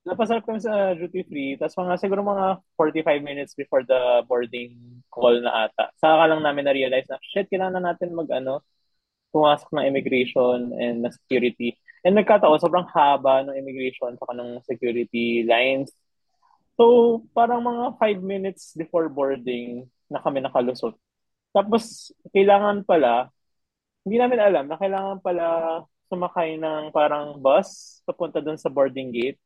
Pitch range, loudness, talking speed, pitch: 130-195 Hz, -22 LUFS, 145 wpm, 155 Hz